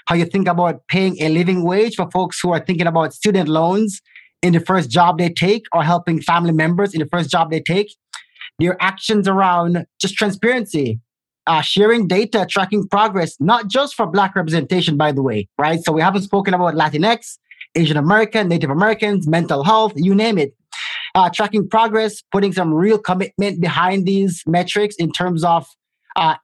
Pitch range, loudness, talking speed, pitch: 165-200 Hz, -17 LUFS, 180 wpm, 180 Hz